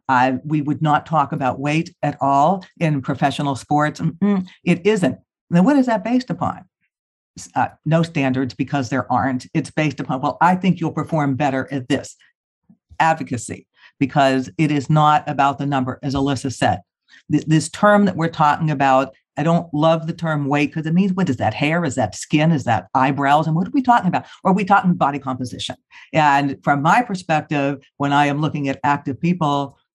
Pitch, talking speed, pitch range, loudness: 145 Hz, 195 wpm, 140-165 Hz, -19 LUFS